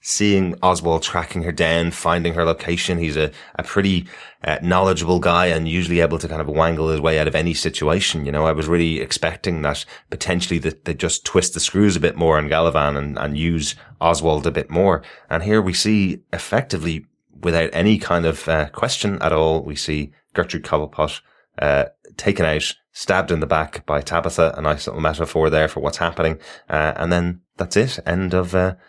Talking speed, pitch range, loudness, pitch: 200 wpm, 80-90 Hz, -20 LUFS, 85 Hz